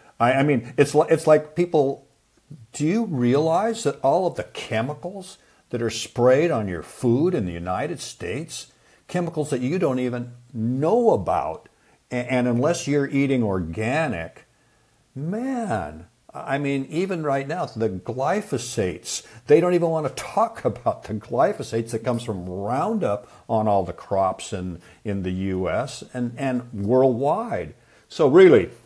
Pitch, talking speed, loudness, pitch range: 125 Hz, 150 wpm, -23 LUFS, 115-155 Hz